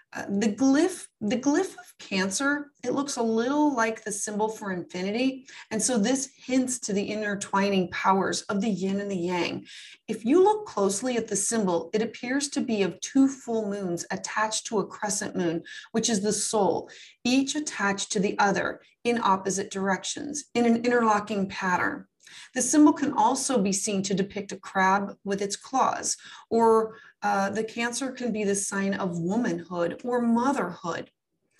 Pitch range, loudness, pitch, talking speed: 195-255 Hz, -26 LUFS, 220 Hz, 175 wpm